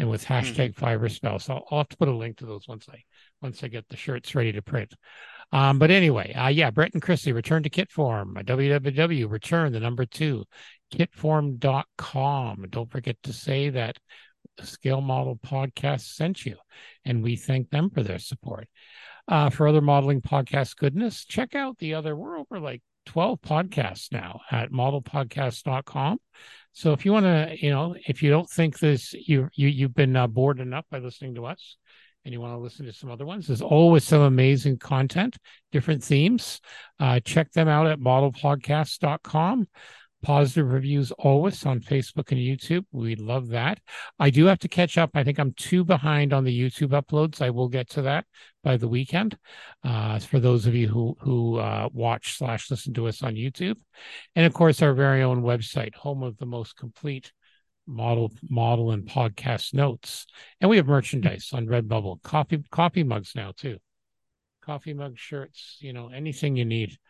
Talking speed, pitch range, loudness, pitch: 185 wpm, 120-155 Hz, -24 LUFS, 135 Hz